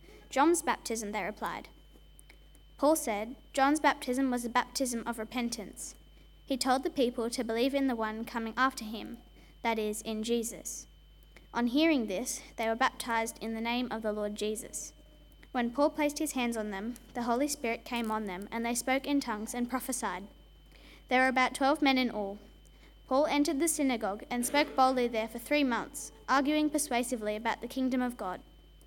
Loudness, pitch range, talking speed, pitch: -31 LUFS, 225-270 Hz, 180 wpm, 245 Hz